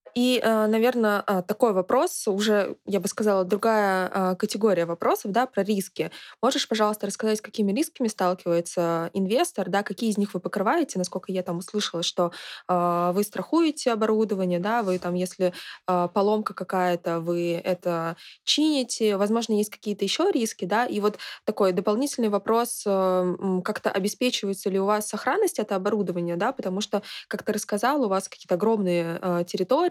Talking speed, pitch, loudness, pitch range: 150 wpm, 205 Hz, -25 LUFS, 185-220 Hz